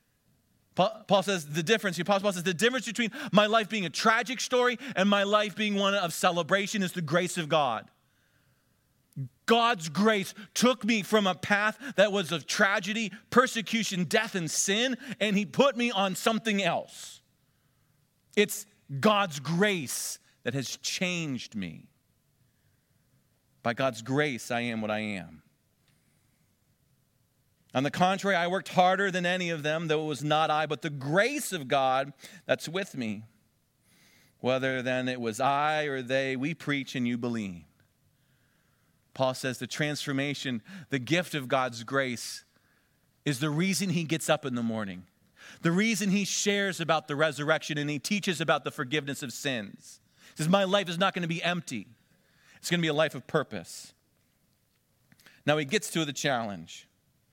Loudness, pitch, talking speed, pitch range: -28 LUFS, 160 Hz, 165 wpm, 135-200 Hz